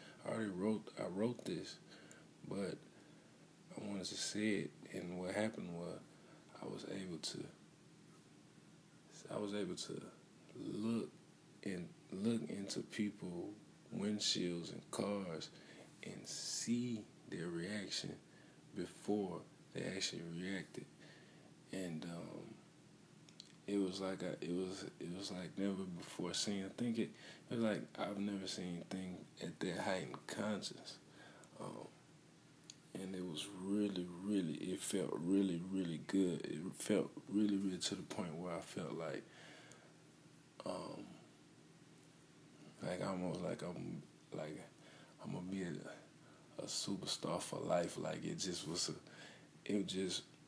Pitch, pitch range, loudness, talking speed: 95 Hz, 90-105 Hz, -43 LUFS, 135 wpm